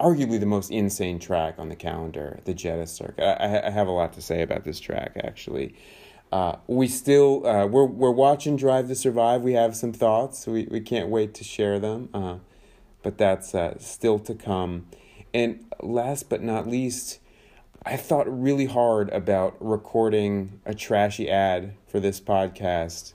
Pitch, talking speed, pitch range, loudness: 110 Hz, 175 wpm, 95-125 Hz, -25 LUFS